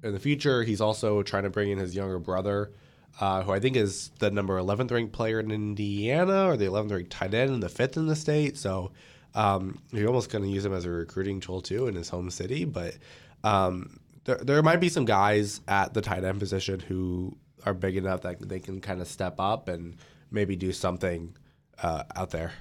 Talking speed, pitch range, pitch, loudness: 225 wpm, 95-115 Hz, 100 Hz, -28 LUFS